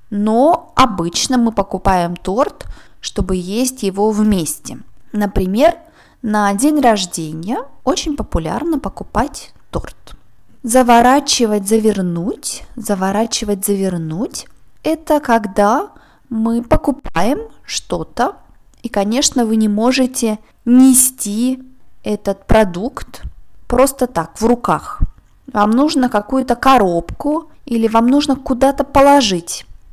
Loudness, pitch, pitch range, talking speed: -15 LUFS, 235 Hz, 205-265 Hz, 95 wpm